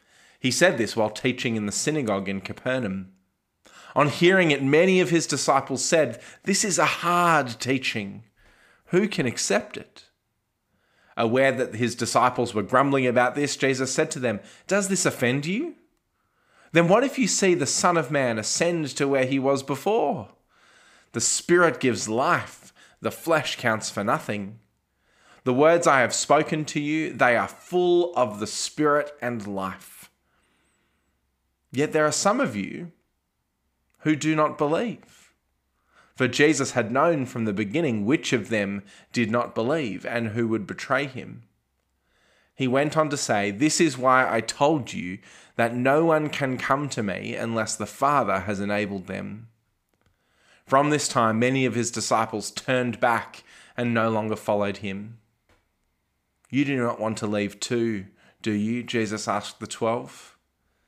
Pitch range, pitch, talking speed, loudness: 110-150 Hz, 125 Hz, 160 wpm, -24 LUFS